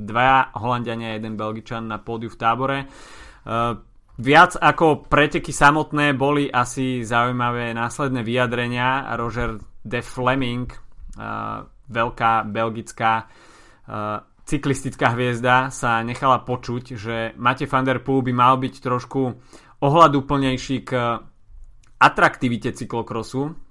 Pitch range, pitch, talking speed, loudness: 115-135 Hz, 125 Hz, 110 wpm, -20 LUFS